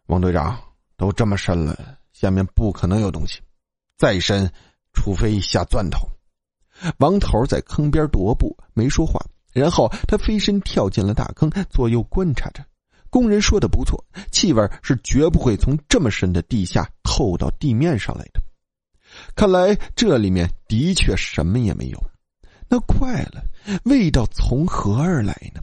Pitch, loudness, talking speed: 110 Hz, -20 LUFS, 225 characters per minute